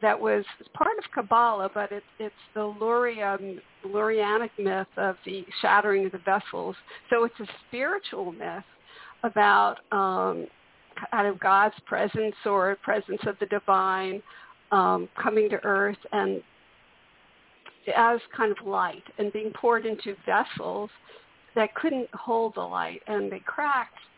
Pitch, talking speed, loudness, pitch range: 210 Hz, 140 wpm, -27 LUFS, 195-230 Hz